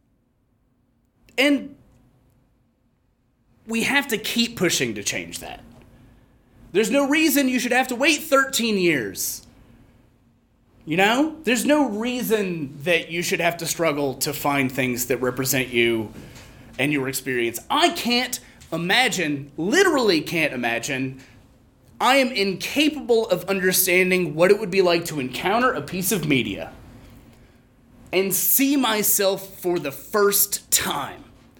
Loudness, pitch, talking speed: -21 LUFS, 170 Hz, 130 wpm